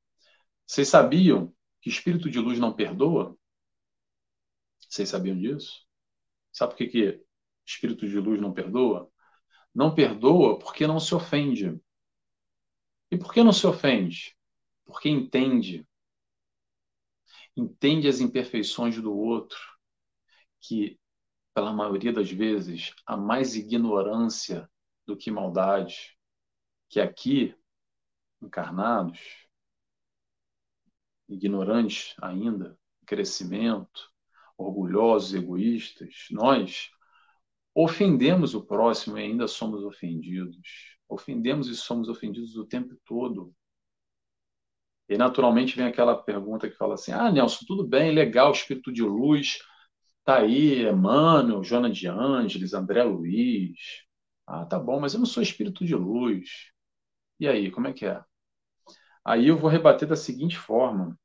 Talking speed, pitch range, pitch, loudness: 120 wpm, 95-140 Hz, 115 Hz, -25 LUFS